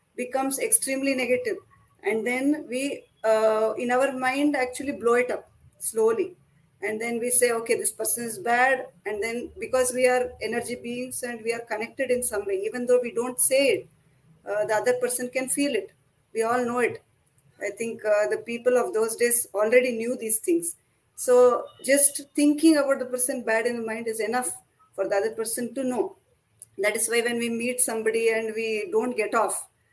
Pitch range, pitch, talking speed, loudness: 220-265 Hz, 245 Hz, 195 wpm, -24 LUFS